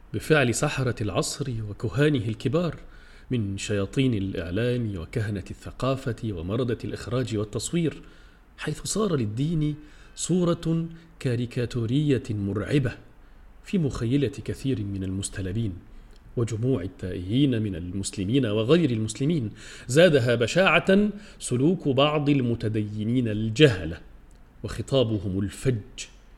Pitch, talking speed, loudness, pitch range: 120 Hz, 85 wpm, -26 LUFS, 105-145 Hz